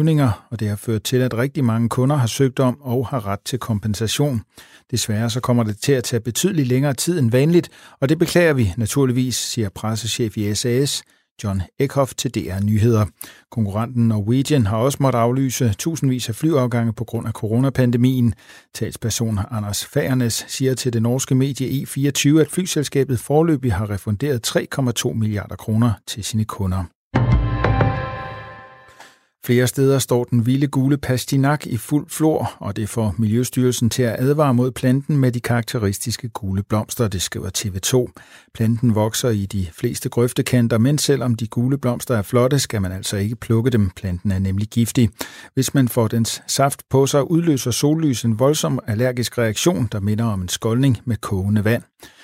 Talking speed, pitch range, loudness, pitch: 170 wpm, 110-135 Hz, -20 LUFS, 120 Hz